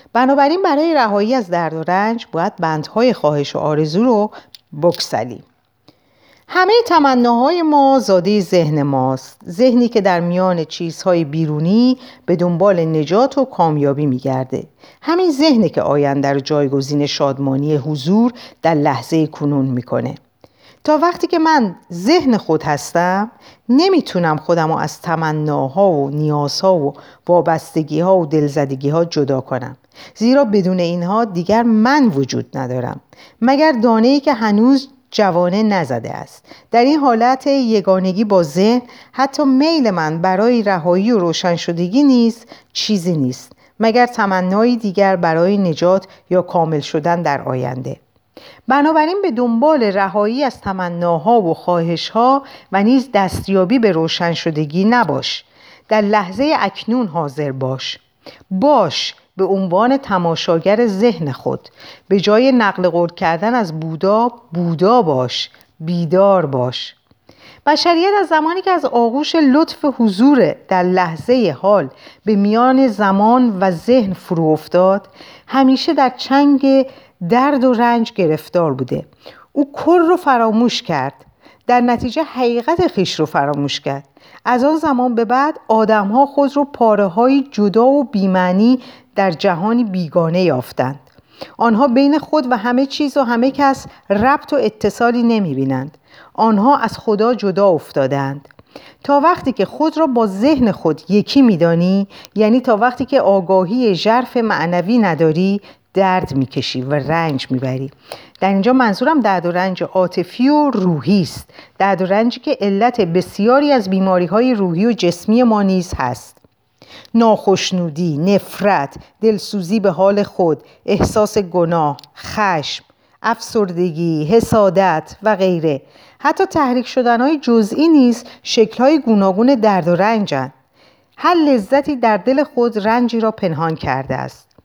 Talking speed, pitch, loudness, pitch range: 135 wpm, 200 Hz, -15 LUFS, 170-250 Hz